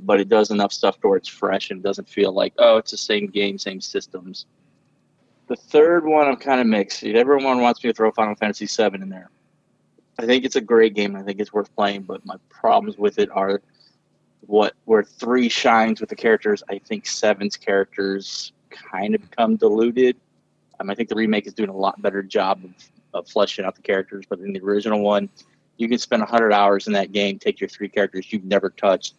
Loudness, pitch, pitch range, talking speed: -20 LUFS, 105 Hz, 100-120 Hz, 220 wpm